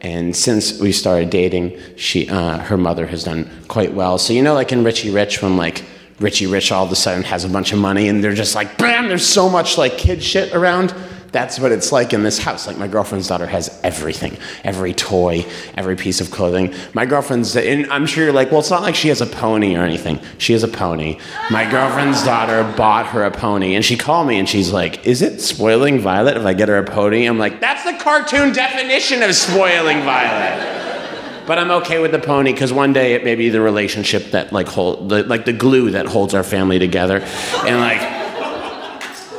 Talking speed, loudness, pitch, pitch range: 220 wpm, -16 LUFS, 105 Hz, 95-140 Hz